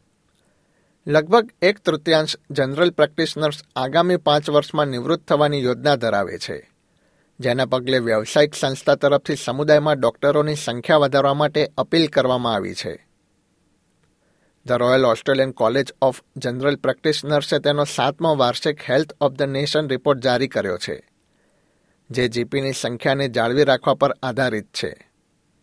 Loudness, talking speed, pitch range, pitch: -20 LUFS, 125 wpm, 130-150 Hz, 140 Hz